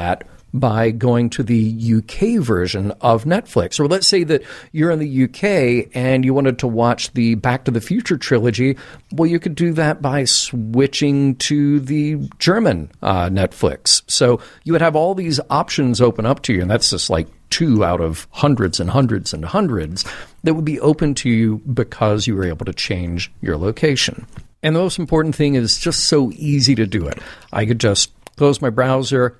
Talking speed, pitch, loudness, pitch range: 190 wpm, 130 Hz, -17 LUFS, 115-150 Hz